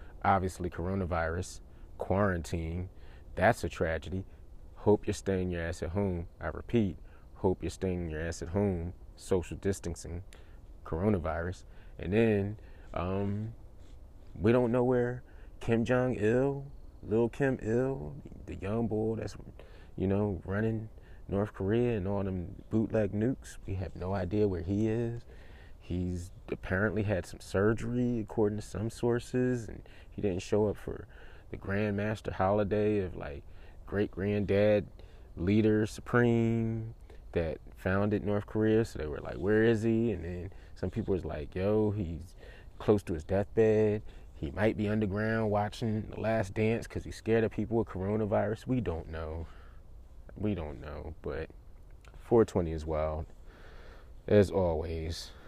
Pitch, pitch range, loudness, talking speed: 100 Hz, 85-110 Hz, -32 LUFS, 145 wpm